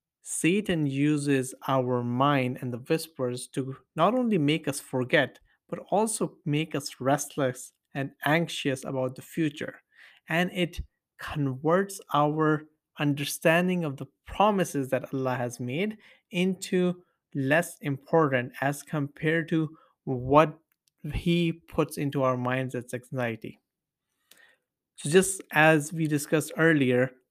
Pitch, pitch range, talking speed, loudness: 150 Hz, 135-165 Hz, 120 wpm, -27 LUFS